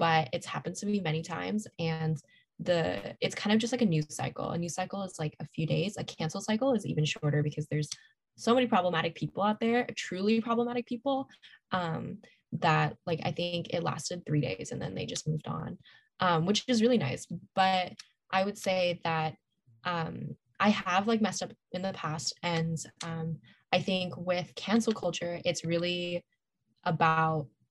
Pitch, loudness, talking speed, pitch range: 175 Hz, -31 LUFS, 185 wpm, 160-205 Hz